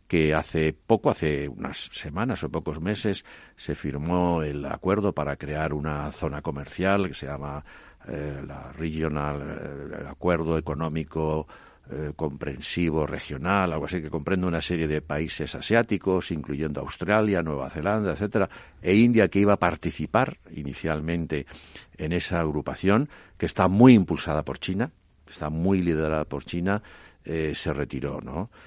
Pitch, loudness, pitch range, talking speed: 80 Hz, -26 LUFS, 75-90 Hz, 145 wpm